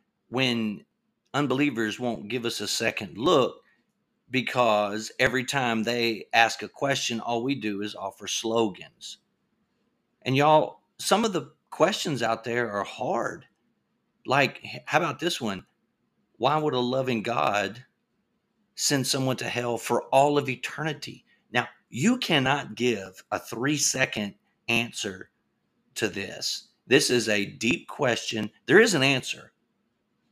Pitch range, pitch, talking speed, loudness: 115-140 Hz, 125 Hz, 135 wpm, -26 LUFS